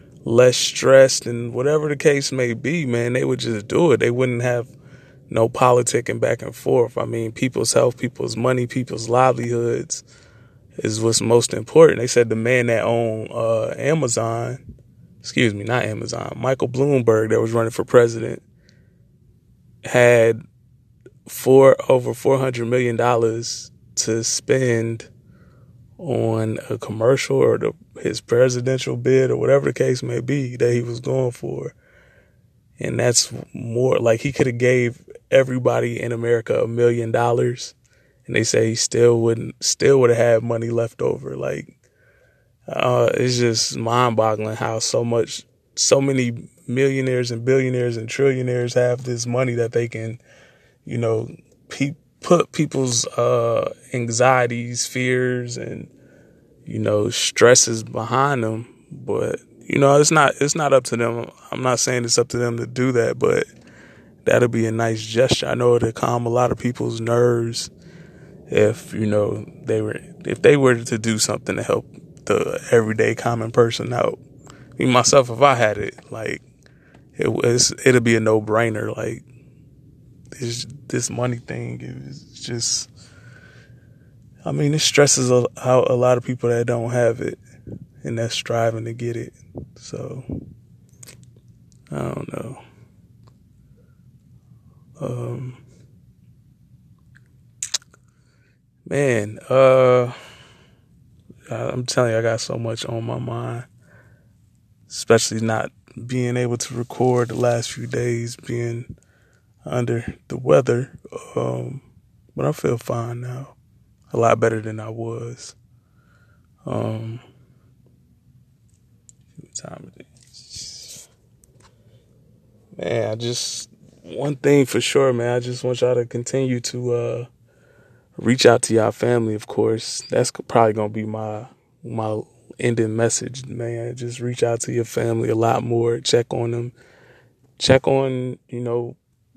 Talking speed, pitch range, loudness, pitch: 140 wpm, 115-125 Hz, -19 LUFS, 120 Hz